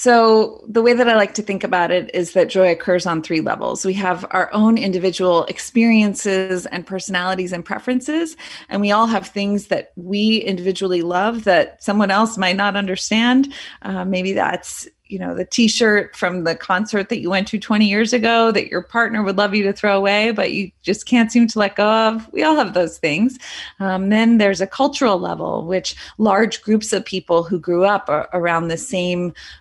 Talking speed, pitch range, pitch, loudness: 205 wpm, 185-220 Hz, 200 Hz, -18 LUFS